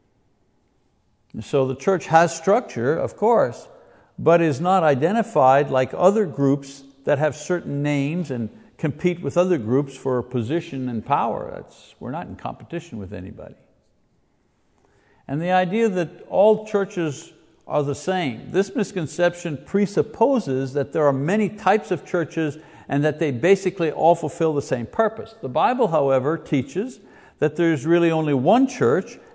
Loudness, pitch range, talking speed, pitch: -21 LUFS, 140-185 Hz, 150 wpm, 160 Hz